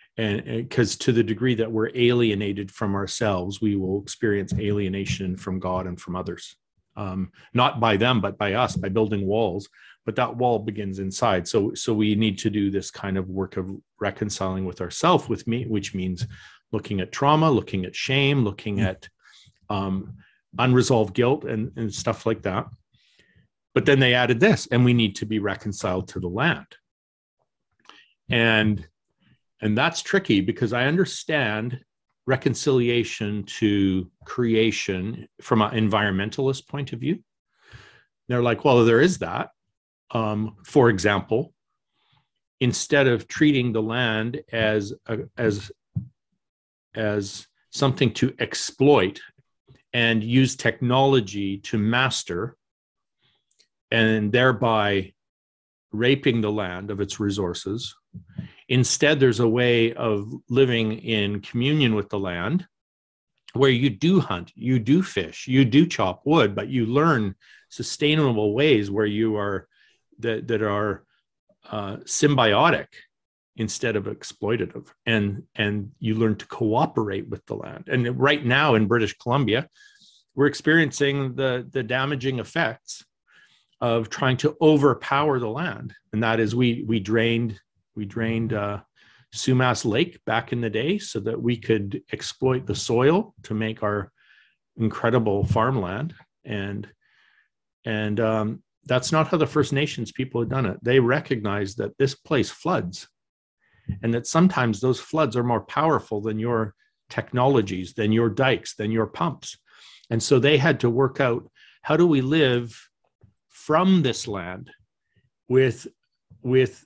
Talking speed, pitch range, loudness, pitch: 140 wpm, 105-130 Hz, -23 LUFS, 115 Hz